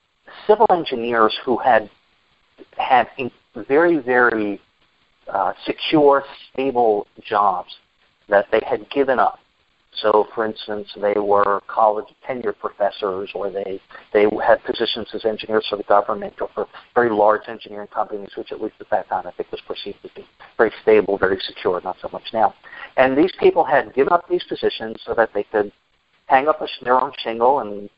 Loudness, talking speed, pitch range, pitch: -19 LUFS, 170 wpm, 105-150 Hz, 110 Hz